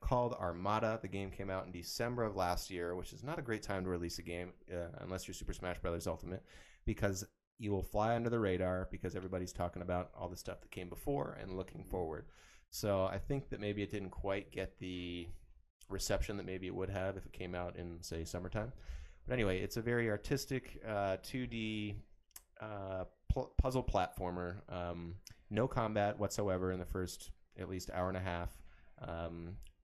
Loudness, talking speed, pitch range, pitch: -40 LUFS, 195 wpm, 90-105 Hz, 95 Hz